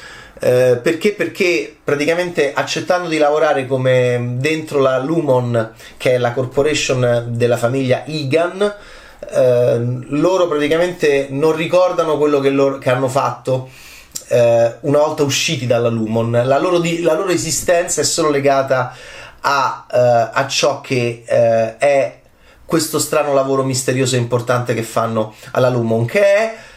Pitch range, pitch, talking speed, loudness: 125-160 Hz, 135 Hz, 140 wpm, -16 LUFS